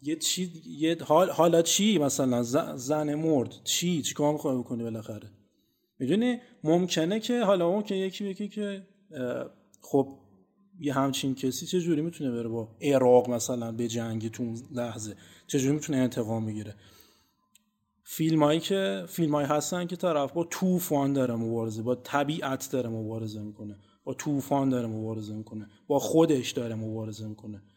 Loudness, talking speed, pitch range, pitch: -28 LUFS, 140 wpm, 115-170 Hz, 135 Hz